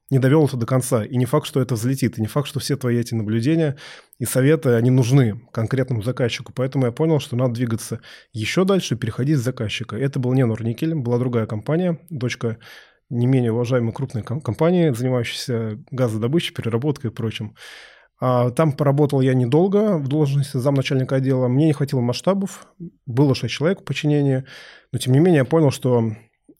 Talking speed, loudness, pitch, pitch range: 180 wpm, -20 LUFS, 130 Hz, 120-150 Hz